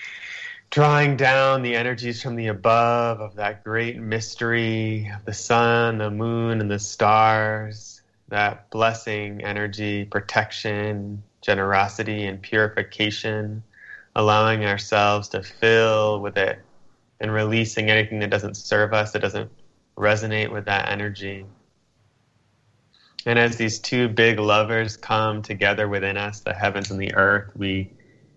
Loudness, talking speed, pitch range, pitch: -22 LUFS, 130 wpm, 105-115 Hz, 110 Hz